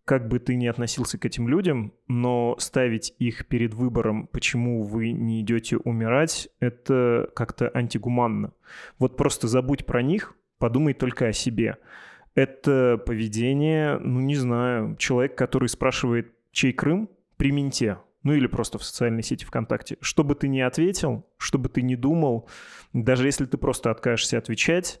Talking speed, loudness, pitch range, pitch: 155 wpm, -25 LUFS, 120-140 Hz, 125 Hz